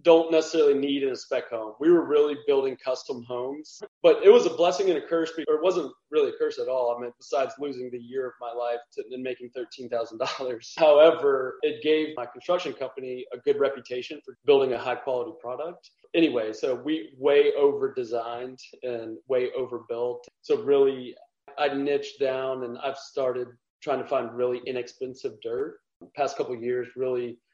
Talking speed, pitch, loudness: 185 wpm, 150 Hz, -26 LUFS